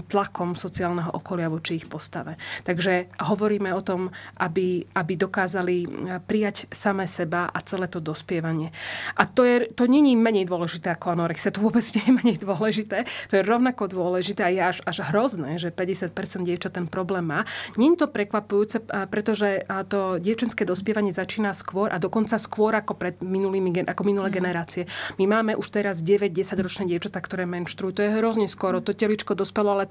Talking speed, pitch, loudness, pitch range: 175 wpm, 195 Hz, -25 LUFS, 180-210 Hz